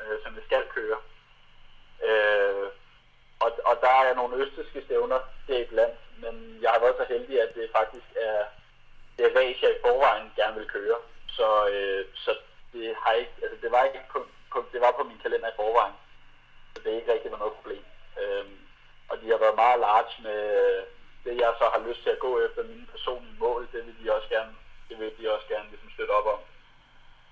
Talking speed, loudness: 210 wpm, -27 LUFS